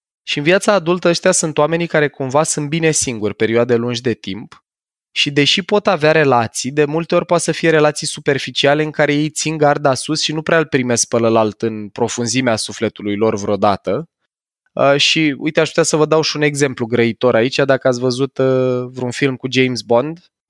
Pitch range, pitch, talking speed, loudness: 120-155 Hz, 145 Hz, 195 wpm, -15 LUFS